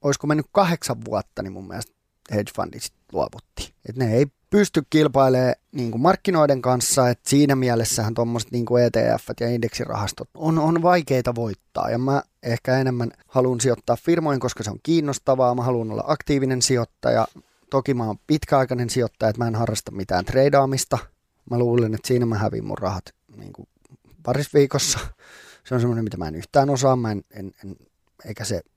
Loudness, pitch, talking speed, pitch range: -22 LUFS, 125 Hz, 175 wpm, 115-140 Hz